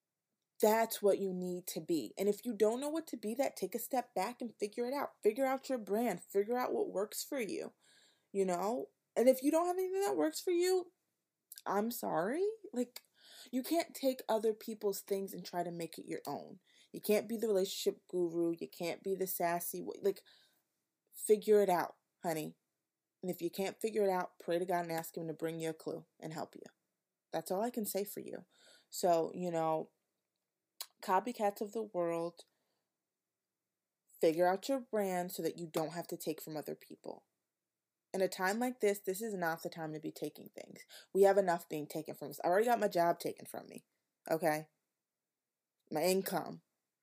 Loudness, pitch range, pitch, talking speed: -36 LUFS, 175-235 Hz, 195 Hz, 205 wpm